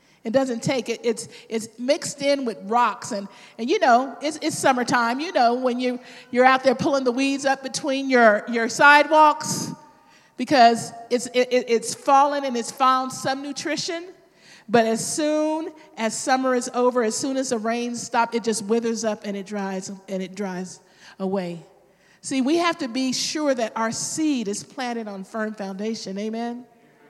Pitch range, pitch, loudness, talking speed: 225-275 Hz, 245 Hz, -22 LUFS, 180 wpm